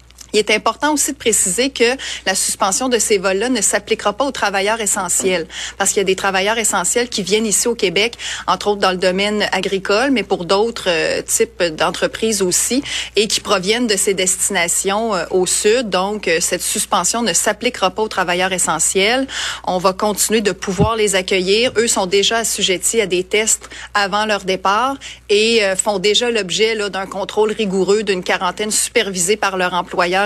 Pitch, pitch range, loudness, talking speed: 205 Hz, 190-220 Hz, -16 LUFS, 185 wpm